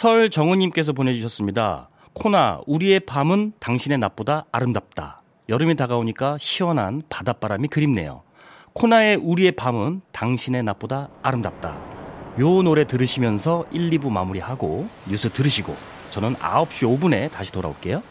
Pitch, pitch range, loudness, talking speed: 135 Hz, 115-160 Hz, -21 LUFS, 330 characters per minute